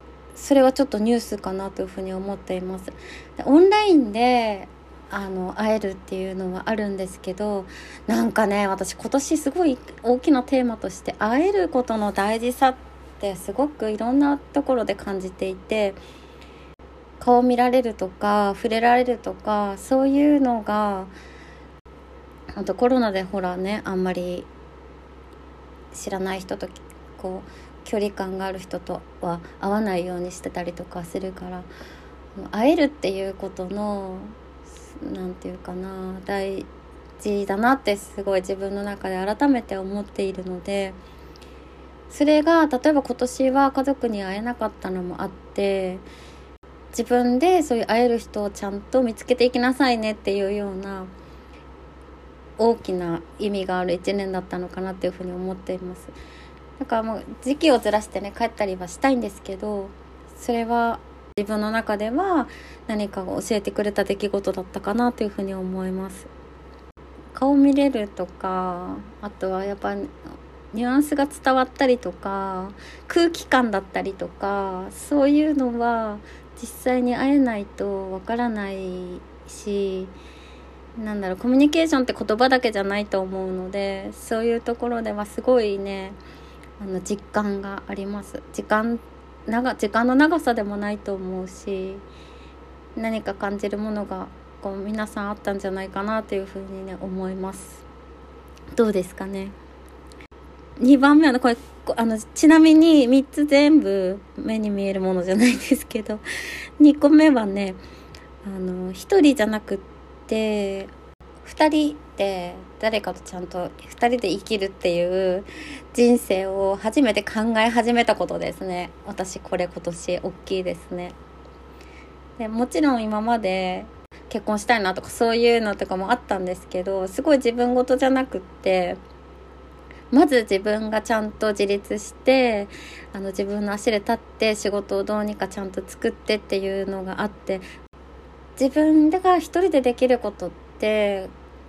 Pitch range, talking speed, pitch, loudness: 185-240 Hz, 300 characters per minute, 205 Hz, -22 LUFS